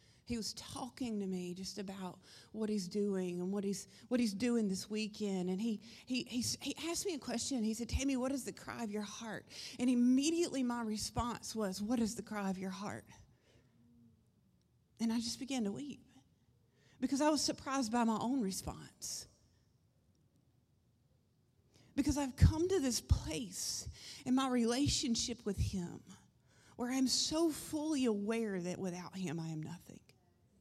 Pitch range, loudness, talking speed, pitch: 195-255 Hz, -37 LUFS, 165 wpm, 225 Hz